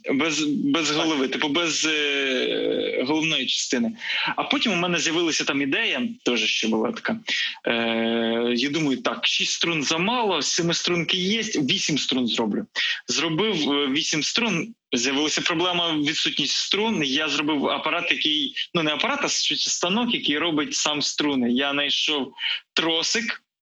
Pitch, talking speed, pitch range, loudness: 165 Hz, 140 wpm, 145-230 Hz, -22 LUFS